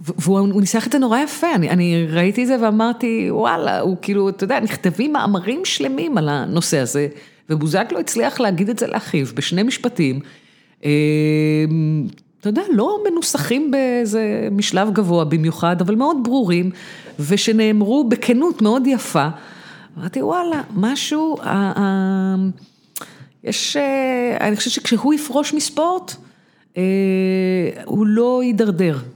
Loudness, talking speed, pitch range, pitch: -18 LUFS, 130 wpm, 180-250 Hz, 210 Hz